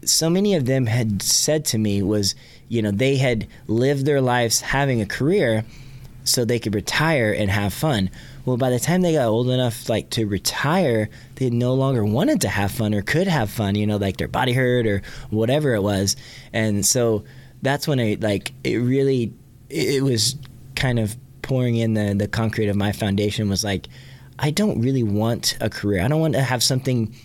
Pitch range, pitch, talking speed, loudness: 105-135 Hz, 120 Hz, 205 wpm, -21 LUFS